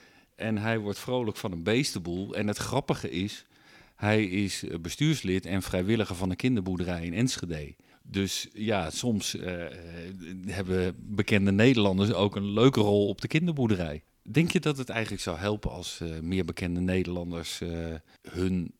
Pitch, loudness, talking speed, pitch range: 100 Hz, -29 LUFS, 155 wpm, 90-110 Hz